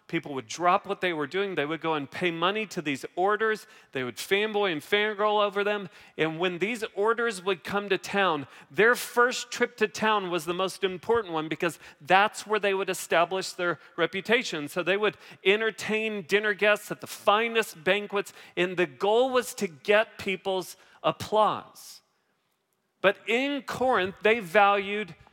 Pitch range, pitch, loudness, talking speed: 180-215 Hz, 200 Hz, -27 LUFS, 170 wpm